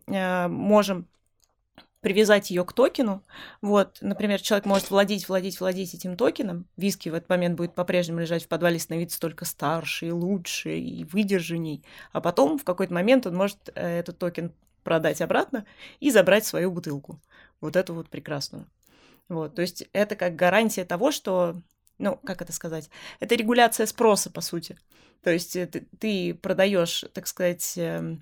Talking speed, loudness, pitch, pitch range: 155 wpm, -25 LUFS, 180 Hz, 170-200 Hz